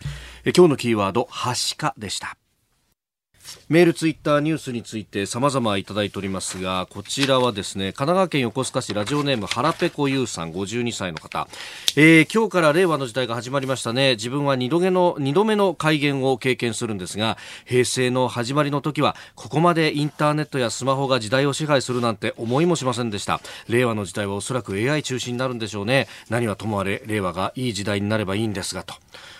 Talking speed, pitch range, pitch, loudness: 410 characters per minute, 105-145 Hz, 125 Hz, -22 LUFS